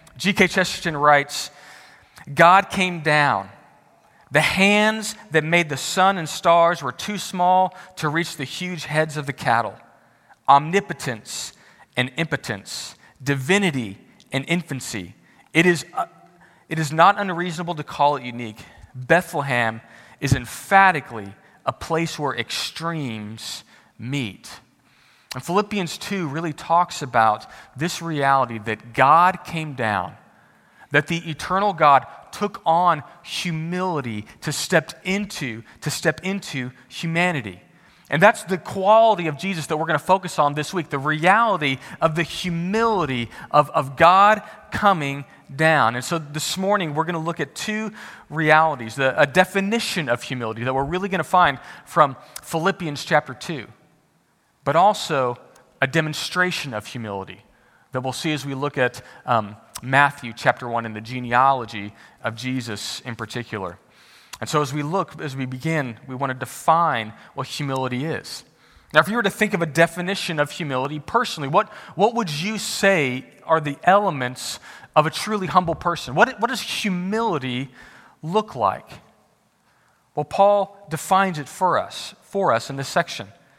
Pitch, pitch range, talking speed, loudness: 155 Hz, 130-180 Hz, 150 wpm, -21 LUFS